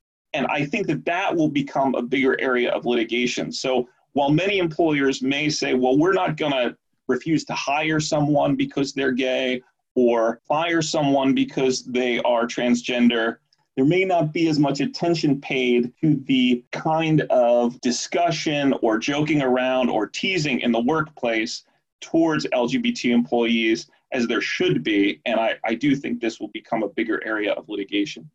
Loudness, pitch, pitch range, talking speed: -22 LUFS, 135 Hz, 125-160 Hz, 165 wpm